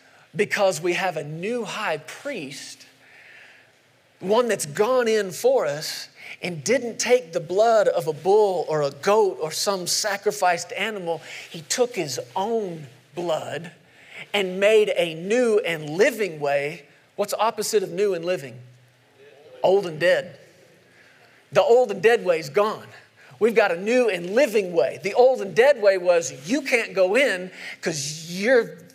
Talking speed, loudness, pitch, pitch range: 155 wpm, -22 LUFS, 195 Hz, 165-225 Hz